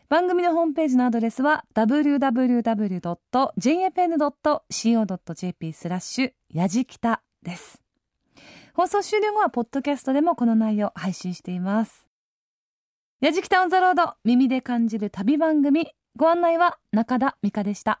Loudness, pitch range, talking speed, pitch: -23 LUFS, 215-315 Hz, 285 characters per minute, 255 Hz